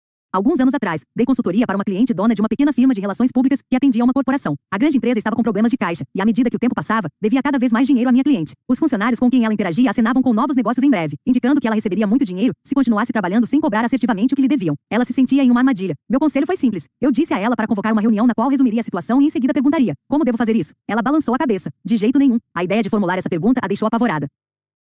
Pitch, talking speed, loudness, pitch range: 240 Hz, 285 wpm, -17 LUFS, 215-265 Hz